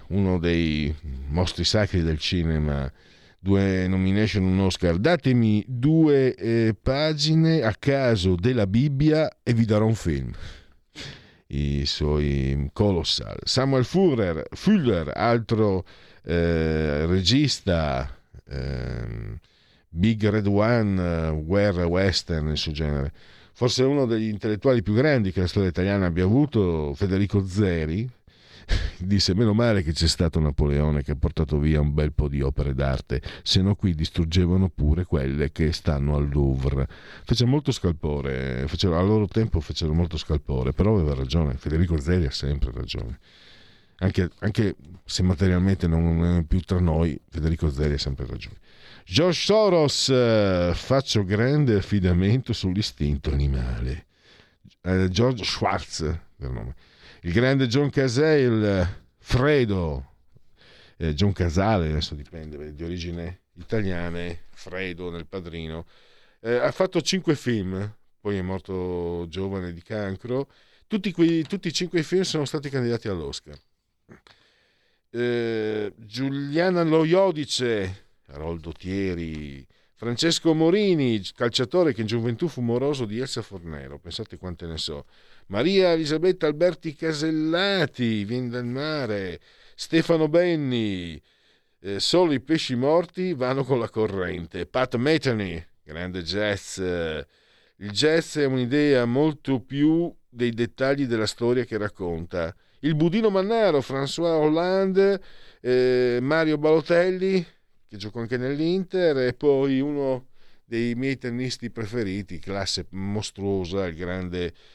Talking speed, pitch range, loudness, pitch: 125 wpm, 85-130 Hz, -24 LUFS, 100 Hz